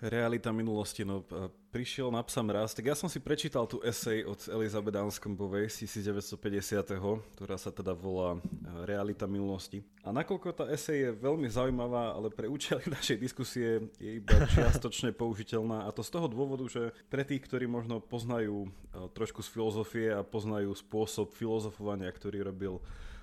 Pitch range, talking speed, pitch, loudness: 100-120 Hz, 155 wpm, 110 Hz, -35 LUFS